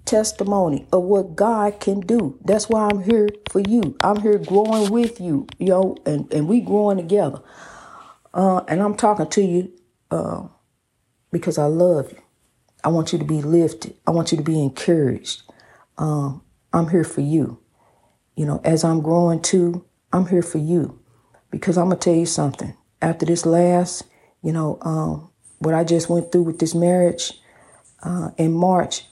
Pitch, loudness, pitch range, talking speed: 175 Hz, -20 LUFS, 160-195 Hz, 175 wpm